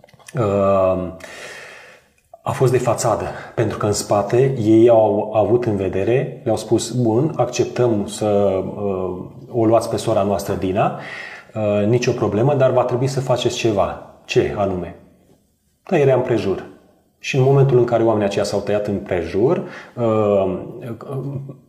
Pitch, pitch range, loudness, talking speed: 115 Hz, 105-125 Hz, -18 LUFS, 150 wpm